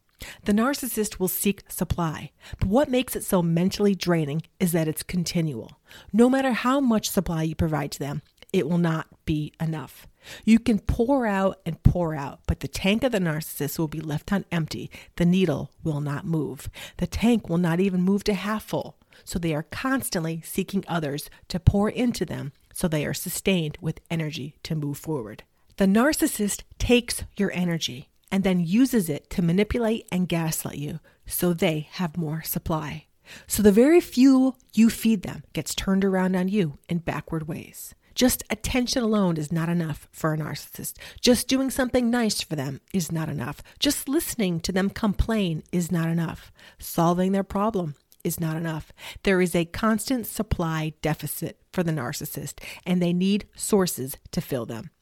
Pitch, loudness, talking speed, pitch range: 175 Hz, -25 LUFS, 180 wpm, 155-205 Hz